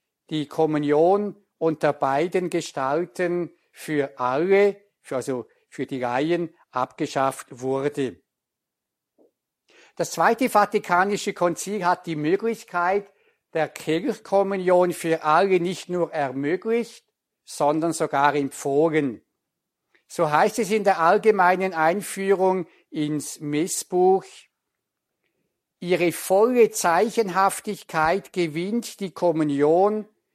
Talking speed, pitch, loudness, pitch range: 90 wpm, 175 Hz, -23 LUFS, 150-195 Hz